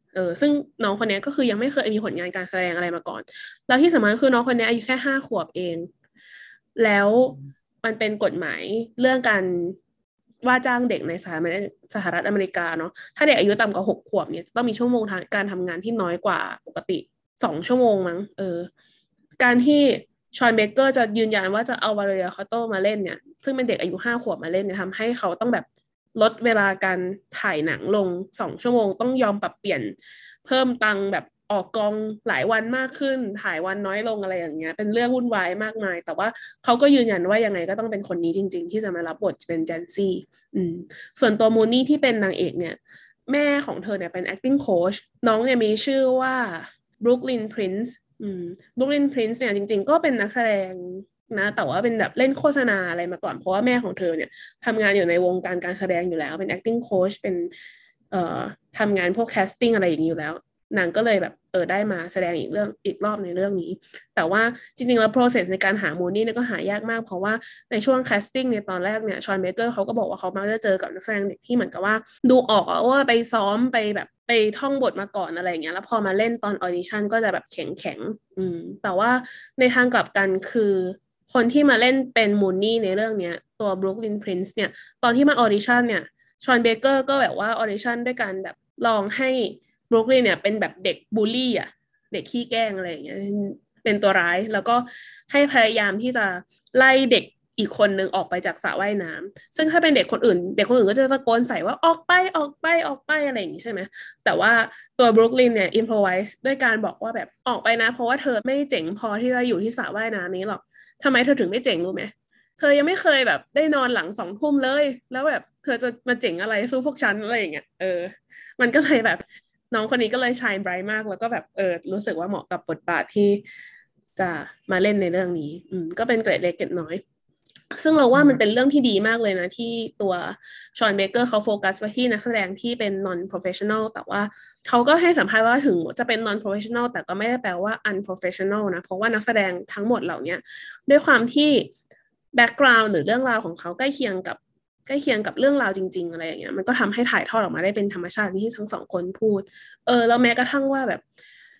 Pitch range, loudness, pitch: 190-245 Hz, -22 LUFS, 220 Hz